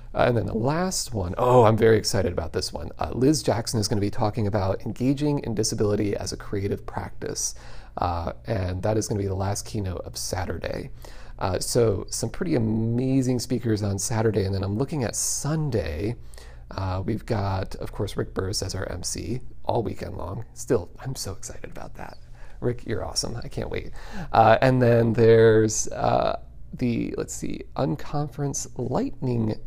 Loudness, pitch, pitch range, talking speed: -25 LUFS, 110 Hz, 100-125 Hz, 180 wpm